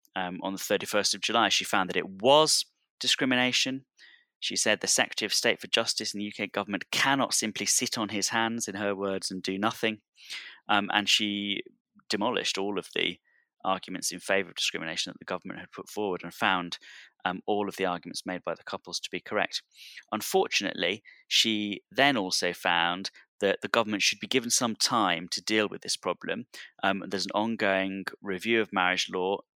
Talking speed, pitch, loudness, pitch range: 190 wpm, 100 Hz, -28 LUFS, 95-110 Hz